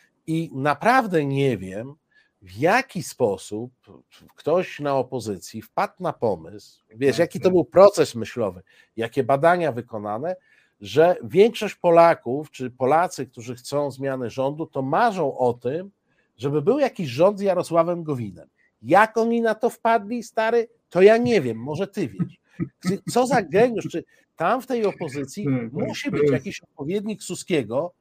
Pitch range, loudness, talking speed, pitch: 135-205 Hz, -22 LUFS, 145 wpm, 165 Hz